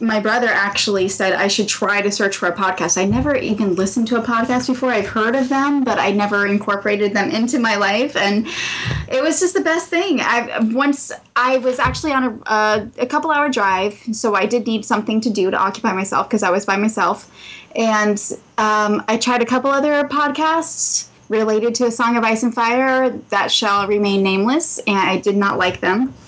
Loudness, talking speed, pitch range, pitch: -17 LUFS, 210 wpm, 200-255 Hz, 220 Hz